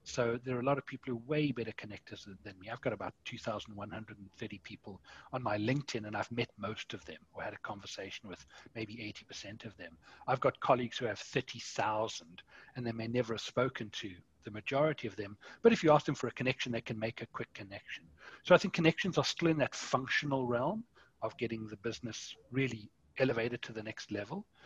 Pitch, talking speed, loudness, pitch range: 115 Hz, 215 wpm, -36 LUFS, 110-135 Hz